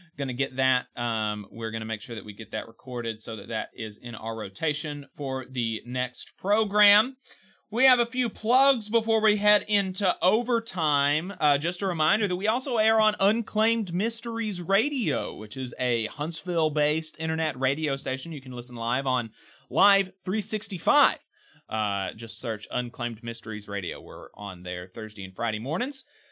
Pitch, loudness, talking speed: 150 Hz, -27 LUFS, 175 wpm